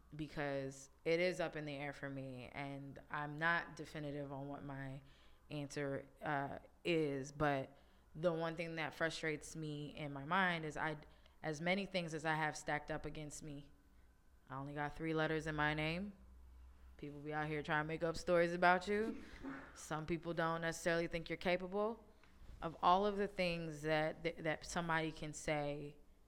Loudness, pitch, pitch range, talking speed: -41 LUFS, 155 Hz, 145-165 Hz, 180 wpm